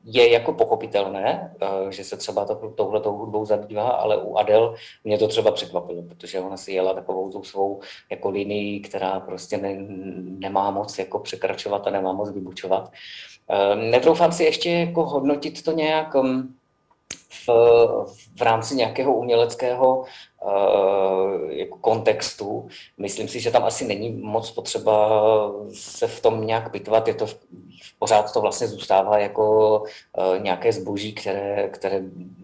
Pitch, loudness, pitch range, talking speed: 105 Hz, -22 LUFS, 95-115 Hz, 140 wpm